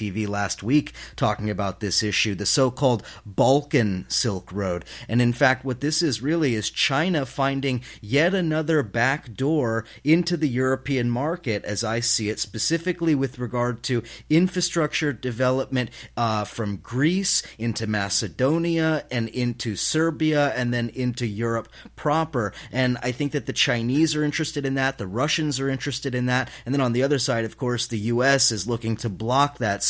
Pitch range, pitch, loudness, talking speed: 115-145 Hz, 125 Hz, -23 LUFS, 165 wpm